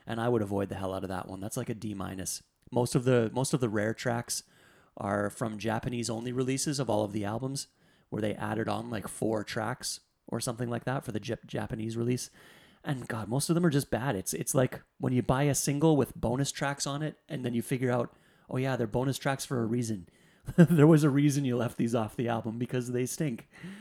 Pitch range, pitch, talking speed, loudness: 110-140 Hz, 125 Hz, 240 wpm, -31 LUFS